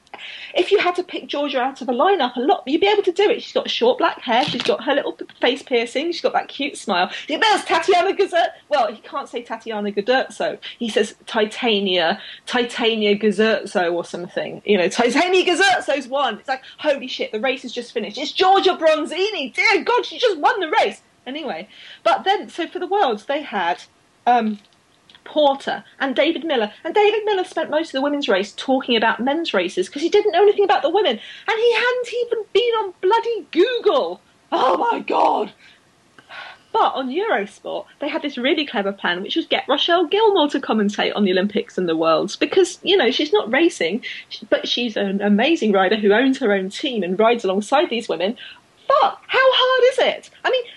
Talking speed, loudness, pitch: 205 wpm, -19 LUFS, 295 Hz